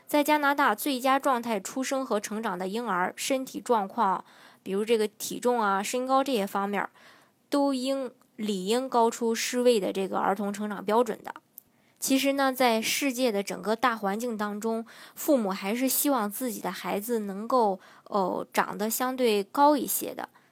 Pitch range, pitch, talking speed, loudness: 205-265 Hz, 235 Hz, 255 characters per minute, -27 LUFS